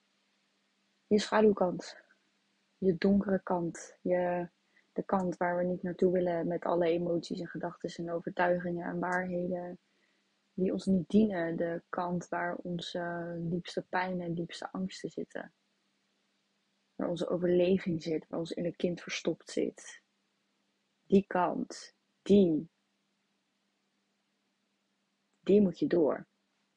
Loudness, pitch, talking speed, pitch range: -32 LUFS, 180 Hz, 120 wpm, 170-185 Hz